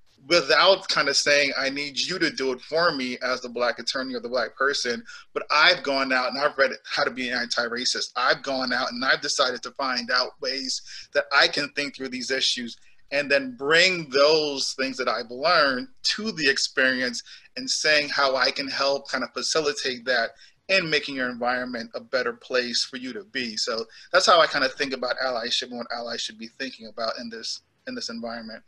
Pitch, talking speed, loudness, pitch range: 130 Hz, 215 wpm, -23 LUFS, 125-145 Hz